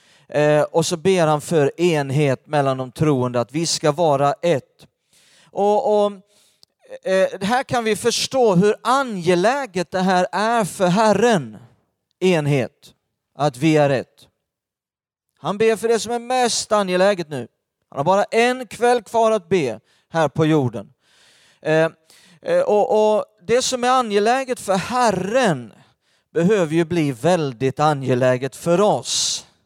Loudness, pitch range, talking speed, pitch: -19 LUFS, 150-225 Hz, 140 wpm, 180 Hz